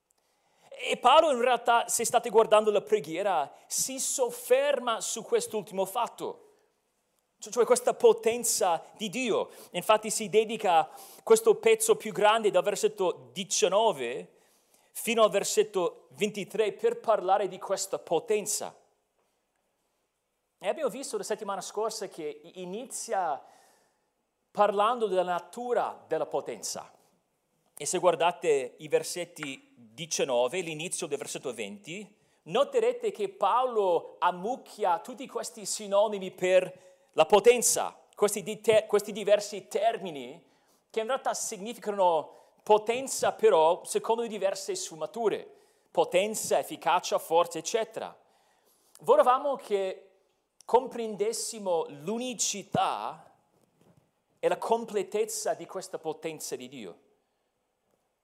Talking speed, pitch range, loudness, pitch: 105 wpm, 195-320 Hz, -28 LUFS, 220 Hz